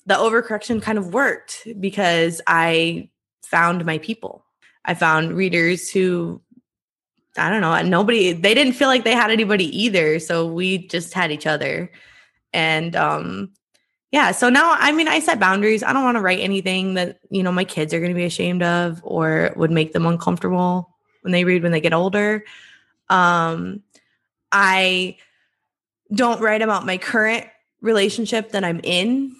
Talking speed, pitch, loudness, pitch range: 165 wpm, 185 Hz, -18 LUFS, 170-220 Hz